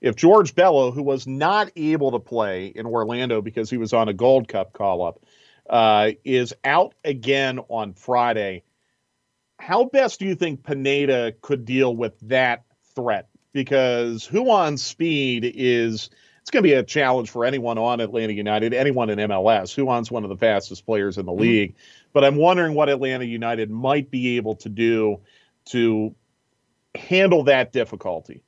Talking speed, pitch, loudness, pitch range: 165 wpm, 125 Hz, -21 LUFS, 115-140 Hz